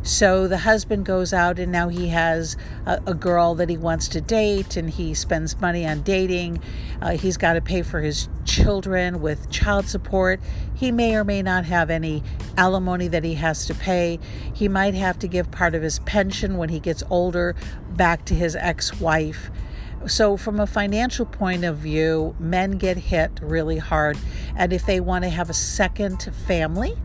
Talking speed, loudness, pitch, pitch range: 190 wpm, -22 LUFS, 175 Hz, 165-190 Hz